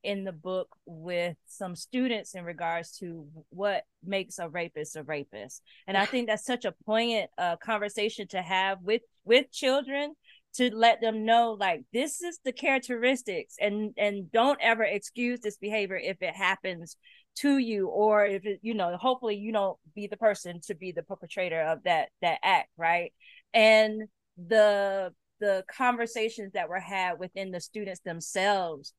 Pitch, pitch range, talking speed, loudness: 205 Hz, 180-230 Hz, 170 wpm, -28 LUFS